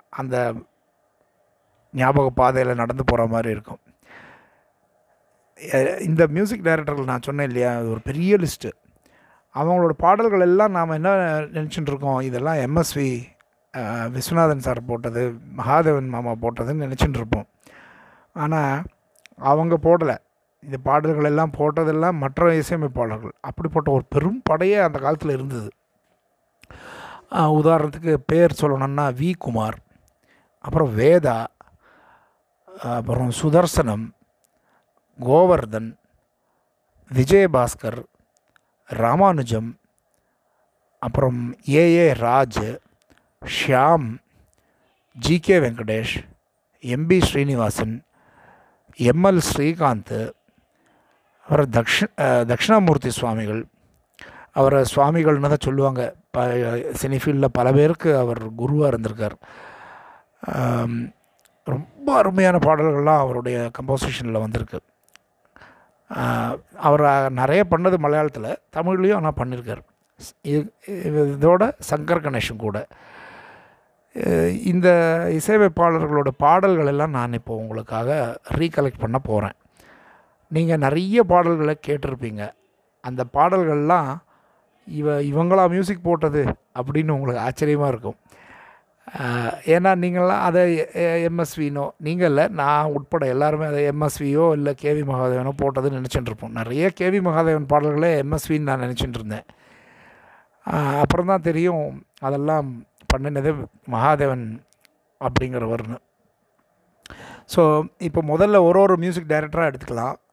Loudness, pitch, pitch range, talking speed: -20 LUFS, 145 Hz, 125-165 Hz, 90 wpm